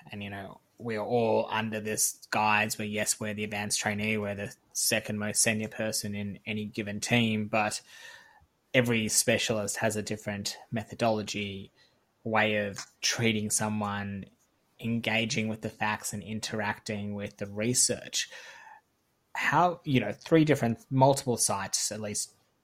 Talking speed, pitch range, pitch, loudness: 140 wpm, 105-115 Hz, 110 Hz, -29 LUFS